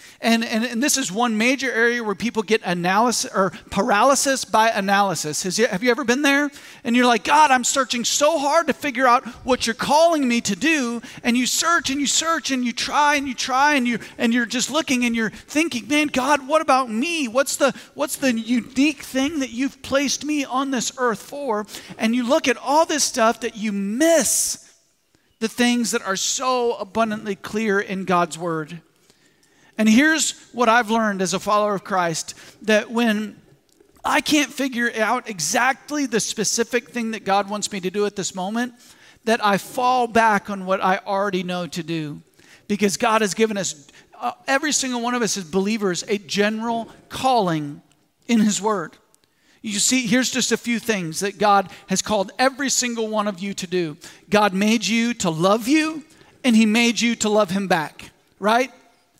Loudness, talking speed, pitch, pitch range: -20 LUFS, 195 wpm, 235 Hz, 205-260 Hz